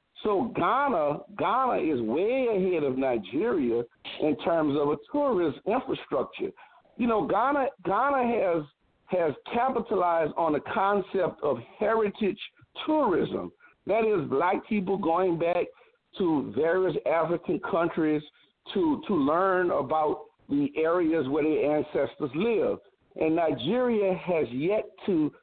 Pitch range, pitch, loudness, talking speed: 160-240 Hz, 185 Hz, -27 LUFS, 125 wpm